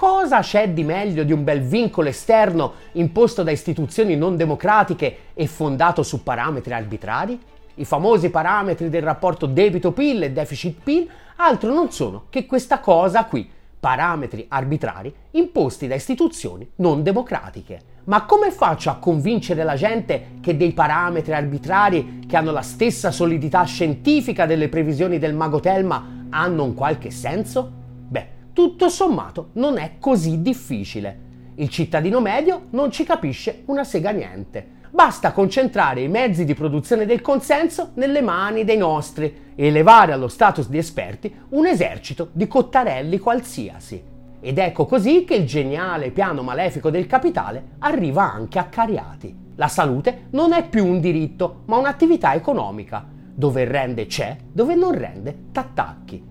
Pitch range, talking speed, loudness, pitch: 150-235 Hz, 145 wpm, -19 LUFS, 175 Hz